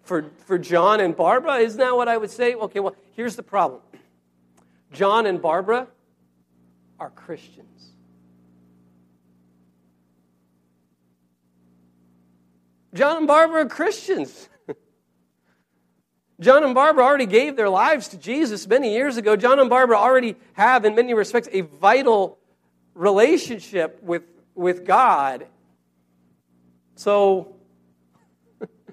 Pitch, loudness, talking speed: 170 Hz, -19 LUFS, 110 wpm